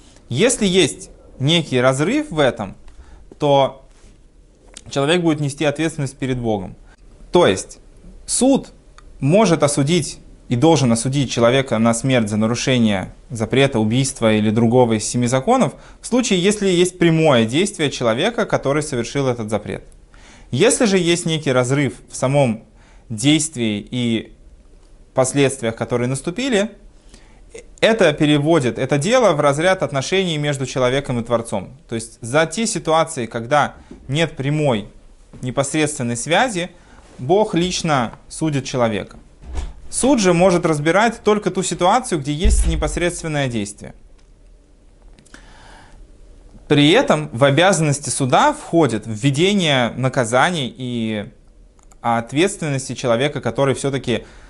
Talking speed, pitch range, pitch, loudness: 115 wpm, 115-165 Hz, 140 Hz, -18 LUFS